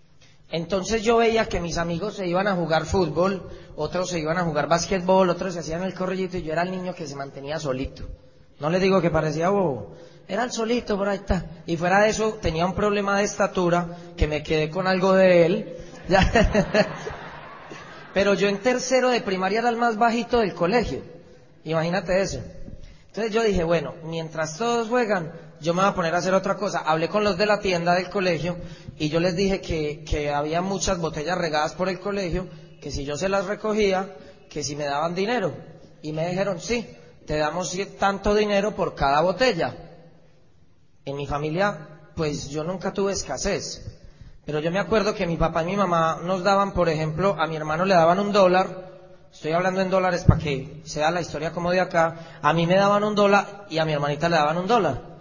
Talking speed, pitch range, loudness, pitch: 205 wpm, 160-195 Hz, -23 LUFS, 180 Hz